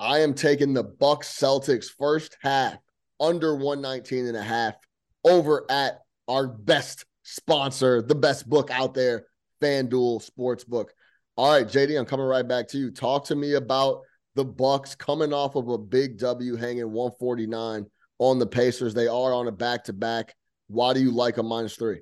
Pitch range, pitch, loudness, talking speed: 120-140 Hz, 130 Hz, -25 LUFS, 170 wpm